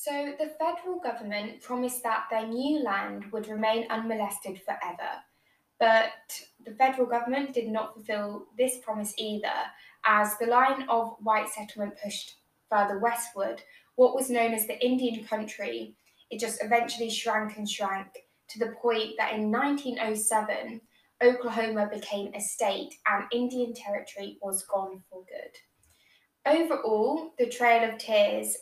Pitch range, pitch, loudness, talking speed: 210-245 Hz, 225 Hz, -29 LUFS, 140 wpm